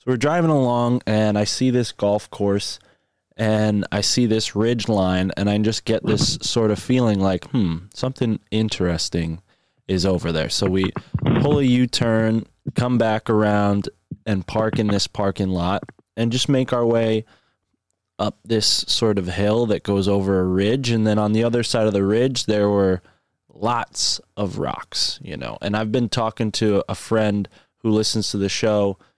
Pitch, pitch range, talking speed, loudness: 110 Hz, 100-115 Hz, 185 wpm, -20 LUFS